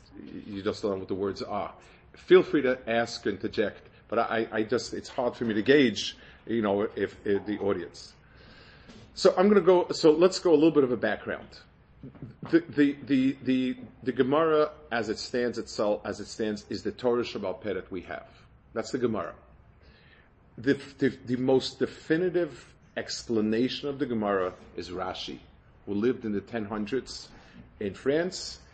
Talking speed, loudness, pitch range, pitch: 180 wpm, -28 LUFS, 110-145 Hz, 125 Hz